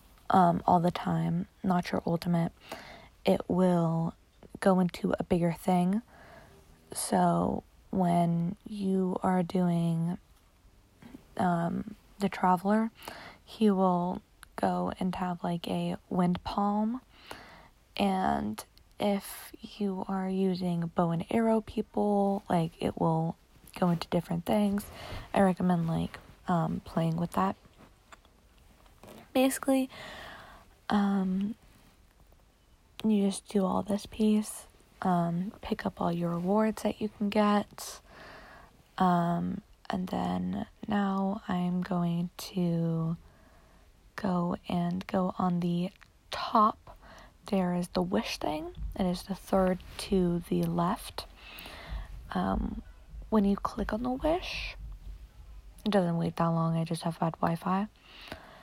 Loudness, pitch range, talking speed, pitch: -30 LUFS, 170-205 Hz, 115 wpm, 185 Hz